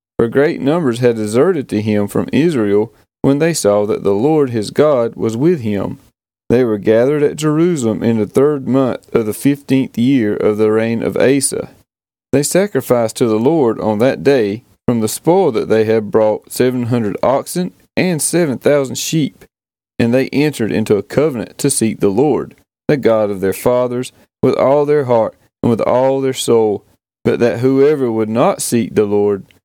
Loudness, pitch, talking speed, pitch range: -15 LUFS, 120 Hz, 185 wpm, 110-140 Hz